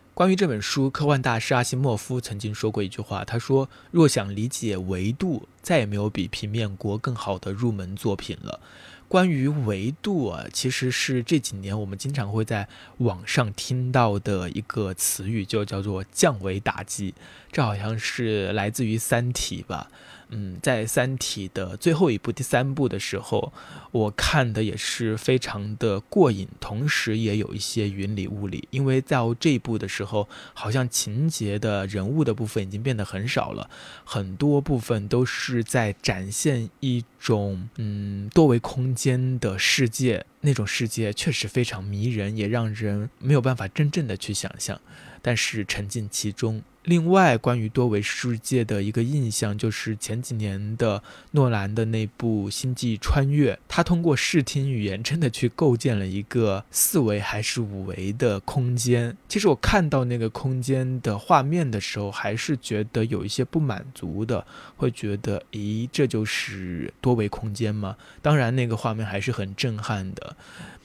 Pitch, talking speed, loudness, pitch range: 115 Hz, 250 characters per minute, -25 LUFS, 105-130 Hz